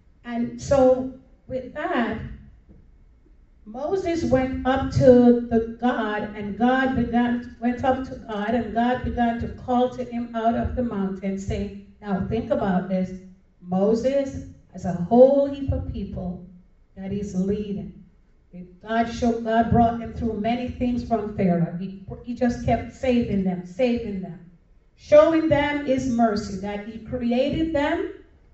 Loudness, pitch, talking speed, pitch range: -23 LUFS, 235 Hz, 145 wpm, 200-255 Hz